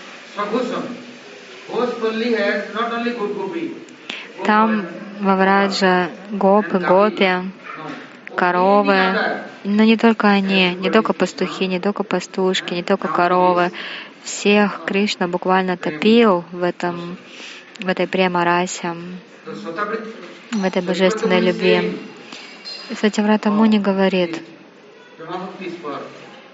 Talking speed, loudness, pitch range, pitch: 75 wpm, -18 LUFS, 180-215 Hz, 195 Hz